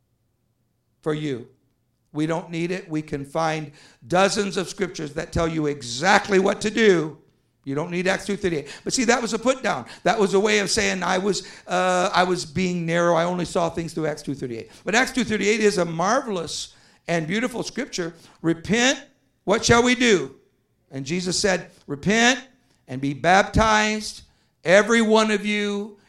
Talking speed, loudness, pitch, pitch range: 190 wpm, -22 LUFS, 180 Hz, 155-210 Hz